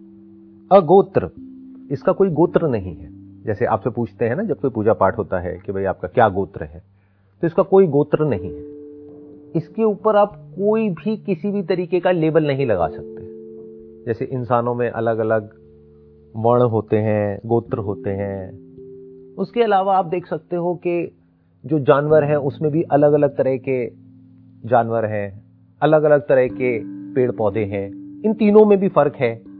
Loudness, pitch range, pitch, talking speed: -19 LUFS, 110-170 Hz, 130 Hz, 170 wpm